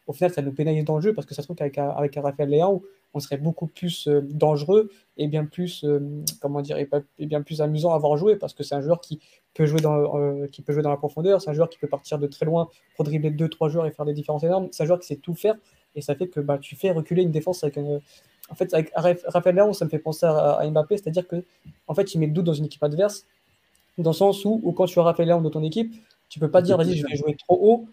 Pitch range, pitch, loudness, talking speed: 150-180 Hz, 155 Hz, -23 LUFS, 295 wpm